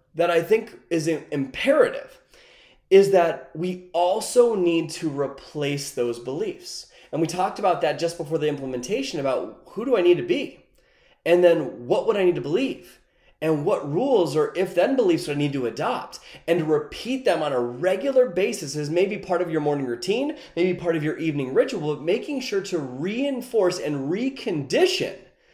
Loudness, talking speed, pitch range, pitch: -23 LUFS, 185 wpm, 150-220 Hz, 175 Hz